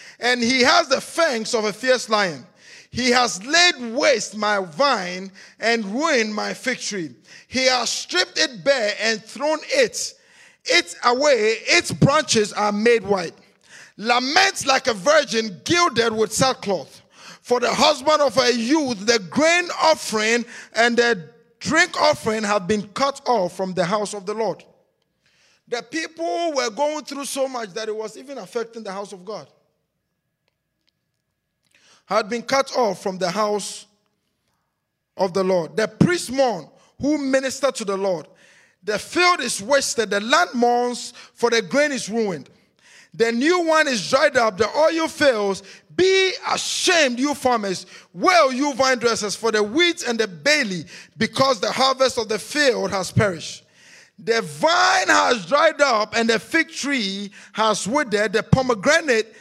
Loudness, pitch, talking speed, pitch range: -20 LUFS, 235 Hz, 155 wpm, 210-285 Hz